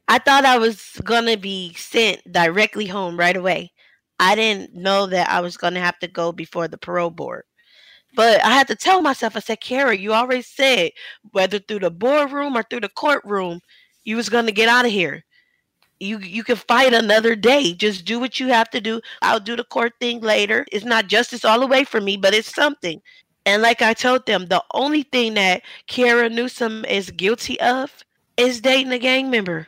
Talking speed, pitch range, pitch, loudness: 210 wpm, 195-250 Hz, 225 Hz, -18 LUFS